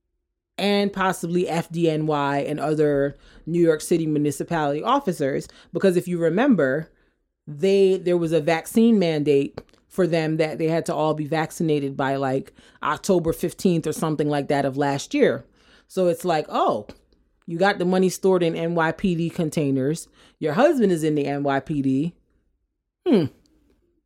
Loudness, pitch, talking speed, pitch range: -22 LUFS, 165 Hz, 145 wpm, 150-180 Hz